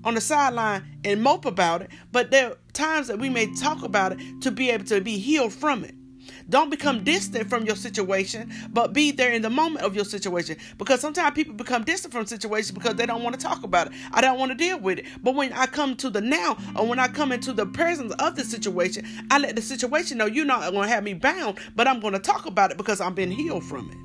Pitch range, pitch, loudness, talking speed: 210-275 Hz, 240 Hz, -24 LUFS, 255 wpm